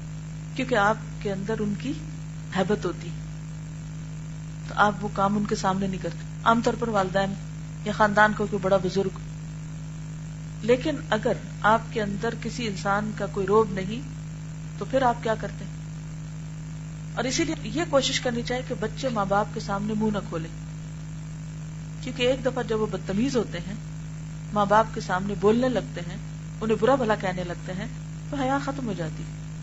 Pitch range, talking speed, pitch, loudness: 155-205 Hz, 170 wpm, 165 Hz, -27 LUFS